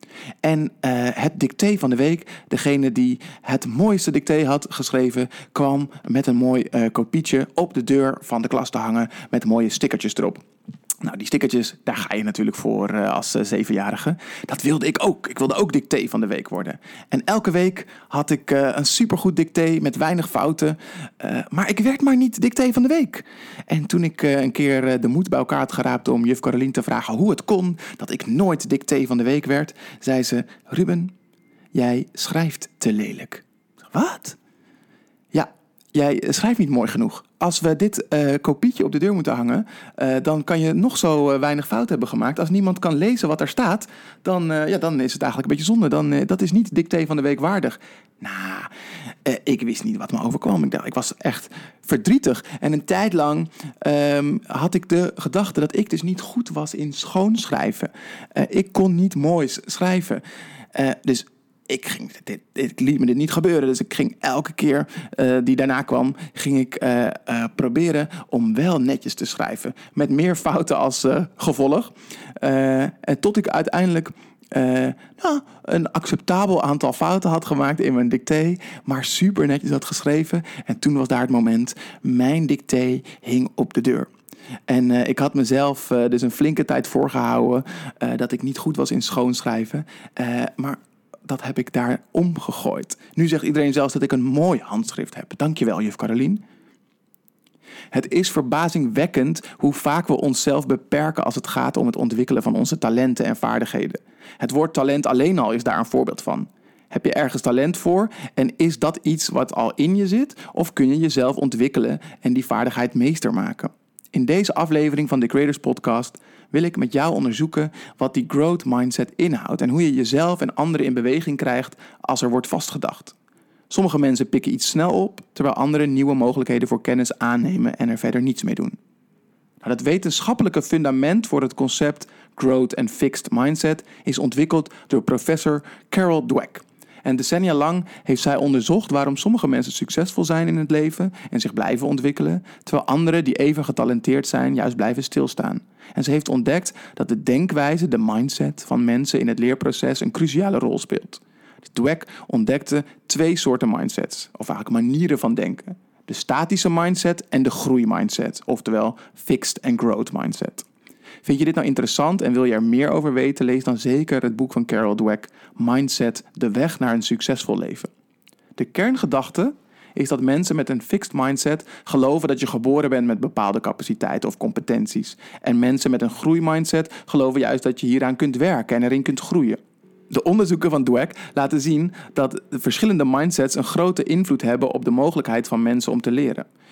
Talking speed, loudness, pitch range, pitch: 190 wpm, -21 LUFS, 130-180 Hz, 150 Hz